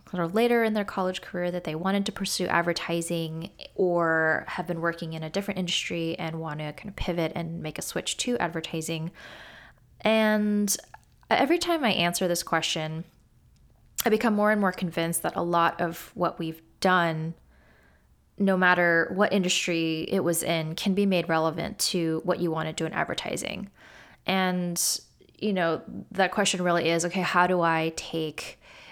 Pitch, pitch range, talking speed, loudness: 175 Hz, 165-190 Hz, 170 wpm, -26 LUFS